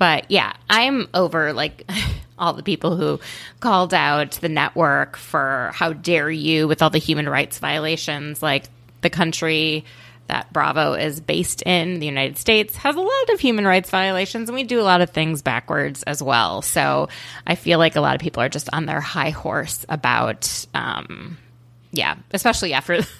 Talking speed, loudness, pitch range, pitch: 180 wpm, -20 LUFS, 145-185 Hz, 160 Hz